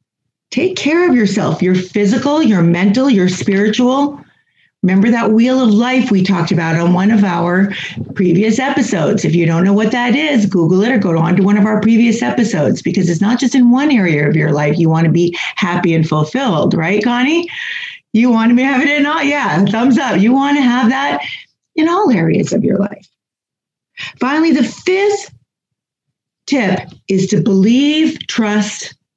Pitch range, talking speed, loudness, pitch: 185-260 Hz, 190 wpm, -13 LUFS, 215 Hz